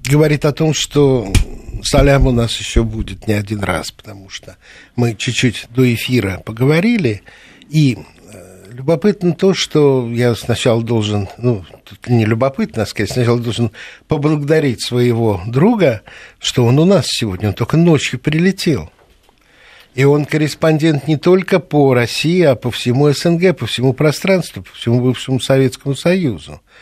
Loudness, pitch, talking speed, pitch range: -15 LUFS, 130 Hz, 145 wpm, 115-155 Hz